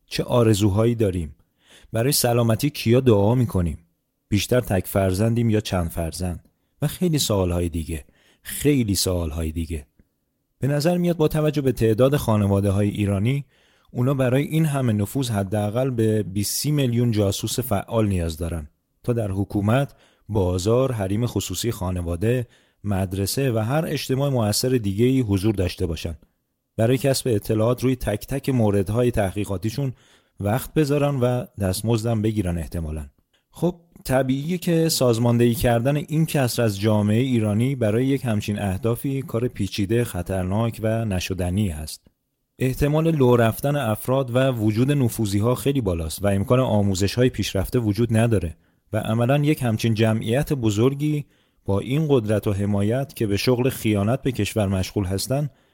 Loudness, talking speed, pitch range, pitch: -22 LUFS, 140 wpm, 100-130 Hz, 115 Hz